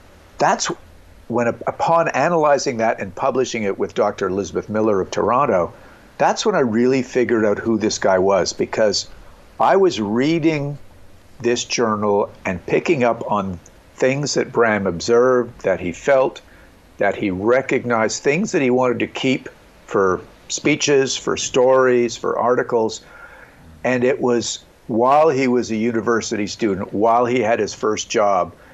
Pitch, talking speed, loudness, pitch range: 120 Hz, 150 wpm, -19 LUFS, 105-130 Hz